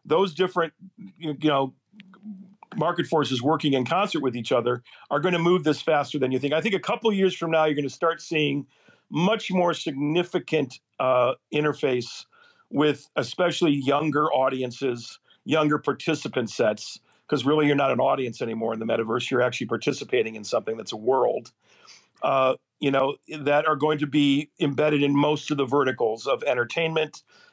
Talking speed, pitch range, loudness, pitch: 175 wpm, 135-170 Hz, -24 LUFS, 150 Hz